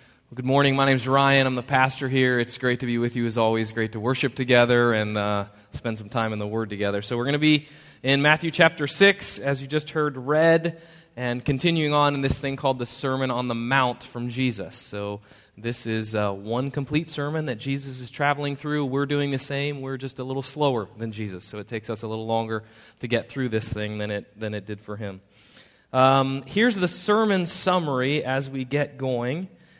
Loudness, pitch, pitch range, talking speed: -24 LUFS, 130 Hz, 115-145 Hz, 220 wpm